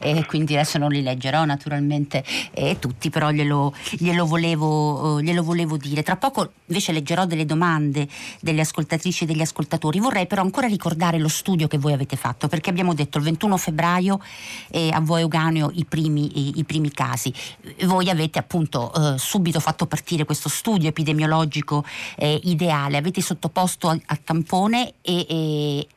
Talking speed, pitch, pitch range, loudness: 165 wpm, 160 Hz, 150-175 Hz, -22 LUFS